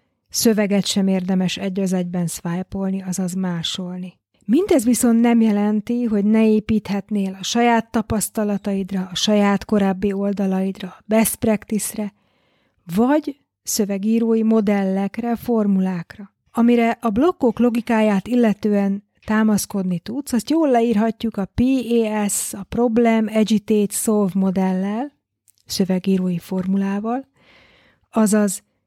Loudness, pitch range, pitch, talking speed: -19 LUFS, 195-230 Hz, 210 Hz, 105 wpm